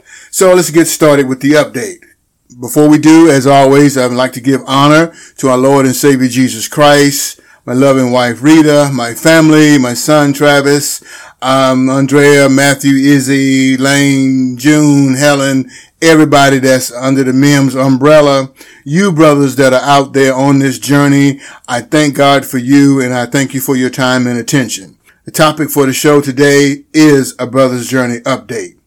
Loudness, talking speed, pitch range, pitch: -8 LUFS, 170 wpm, 130-145 Hz, 140 Hz